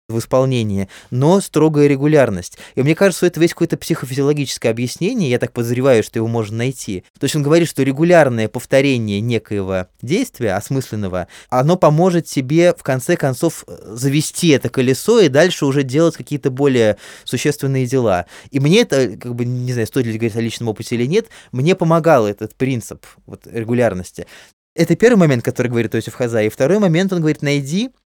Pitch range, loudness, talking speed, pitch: 115-155 Hz, -16 LUFS, 175 wpm, 130 Hz